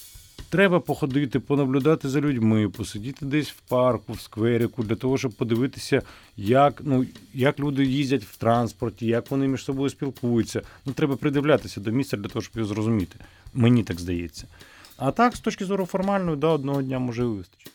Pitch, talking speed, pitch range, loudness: 125 Hz, 175 wpm, 110-140 Hz, -24 LUFS